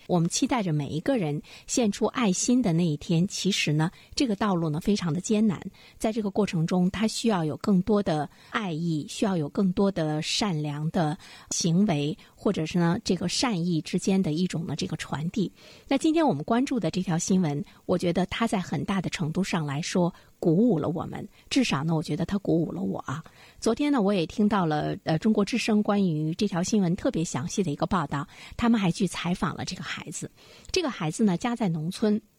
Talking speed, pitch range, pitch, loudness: 305 characters per minute, 160-215 Hz, 185 Hz, -27 LUFS